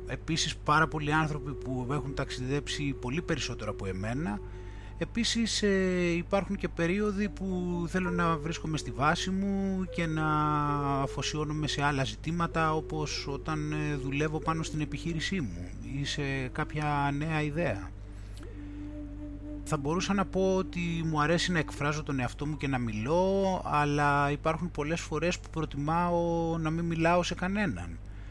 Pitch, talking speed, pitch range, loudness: 150 Hz, 140 wpm, 135-170 Hz, -30 LUFS